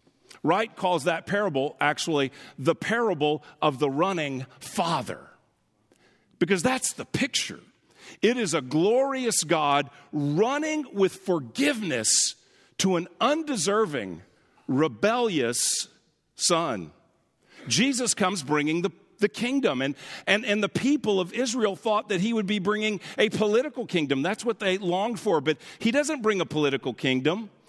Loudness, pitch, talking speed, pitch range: -25 LUFS, 195 Hz, 135 wpm, 155-220 Hz